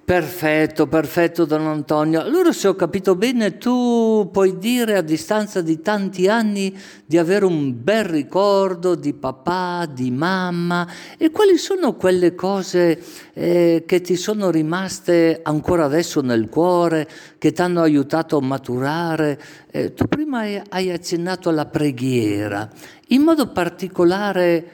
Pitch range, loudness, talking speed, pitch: 155-195 Hz, -19 LUFS, 135 wpm, 175 Hz